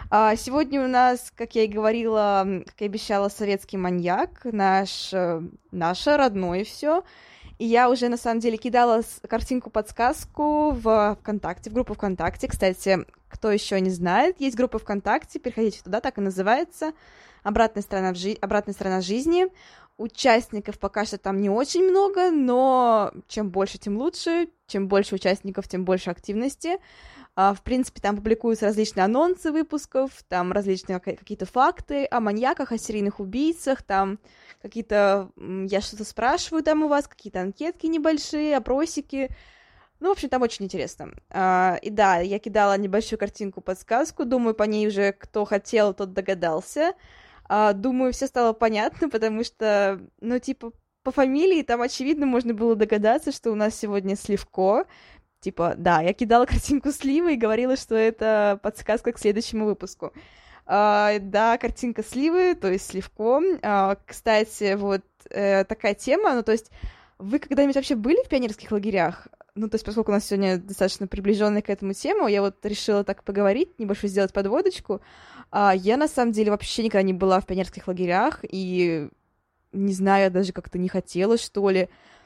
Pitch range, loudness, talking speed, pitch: 195-255 Hz, -24 LUFS, 155 wpm, 215 Hz